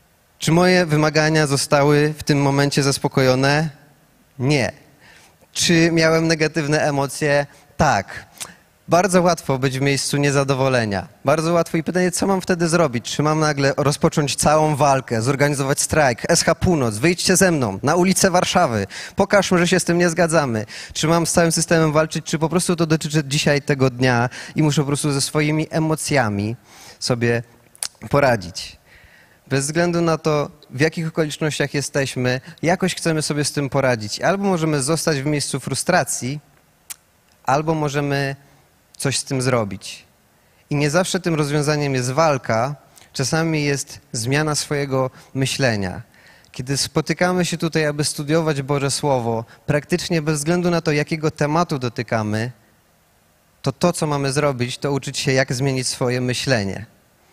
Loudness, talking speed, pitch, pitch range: -19 LUFS, 145 wpm, 145 Hz, 130-165 Hz